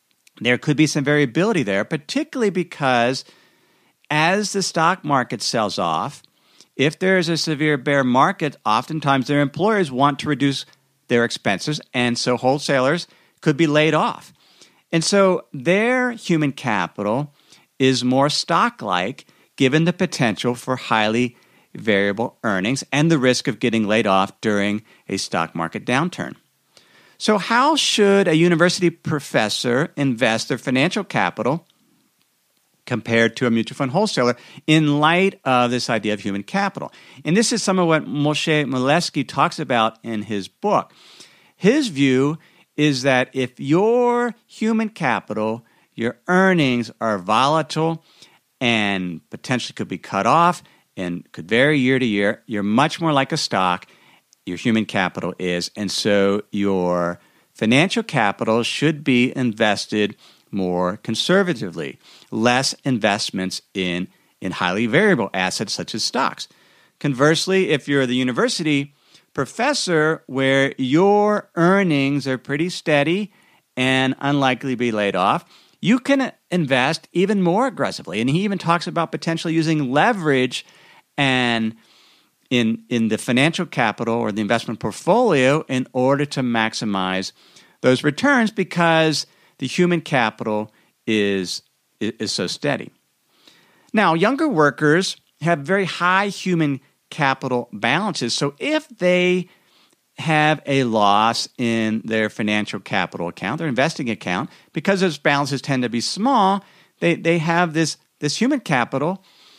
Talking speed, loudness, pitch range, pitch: 135 wpm, -19 LUFS, 115-170 Hz, 140 Hz